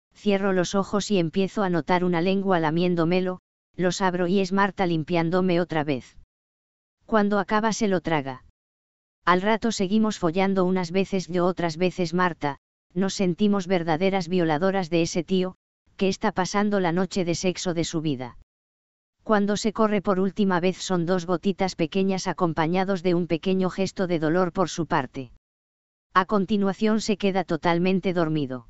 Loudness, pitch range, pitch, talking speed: -24 LUFS, 165-195 Hz, 185 Hz, 160 wpm